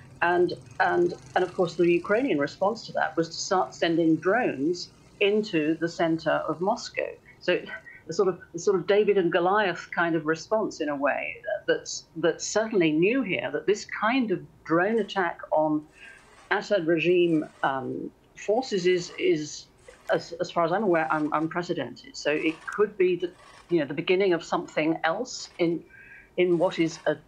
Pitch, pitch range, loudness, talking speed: 180 Hz, 160-210 Hz, -26 LUFS, 175 wpm